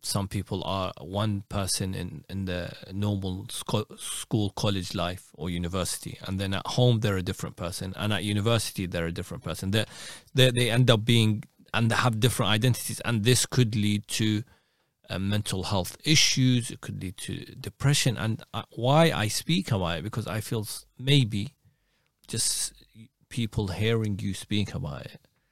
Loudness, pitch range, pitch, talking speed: -27 LUFS, 95-120 Hz, 105 Hz, 170 wpm